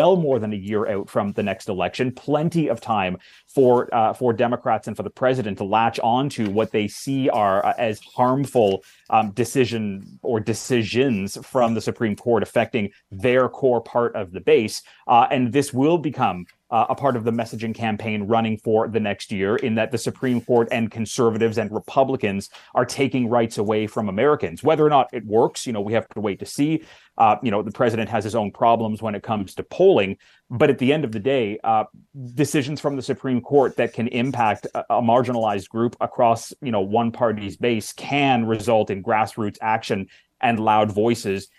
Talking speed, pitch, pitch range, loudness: 200 wpm, 115 Hz, 110-130 Hz, -21 LUFS